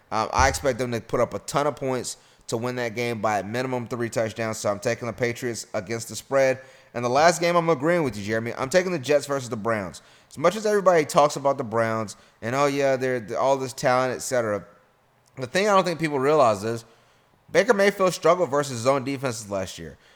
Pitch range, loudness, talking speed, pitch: 115-140 Hz, -24 LUFS, 235 wpm, 125 Hz